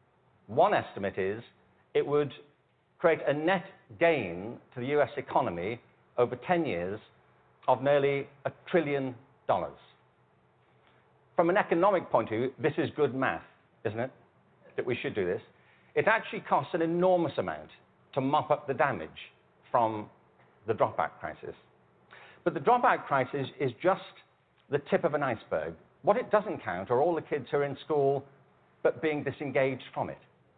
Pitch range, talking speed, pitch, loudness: 130-165 Hz, 160 wpm, 140 Hz, -30 LUFS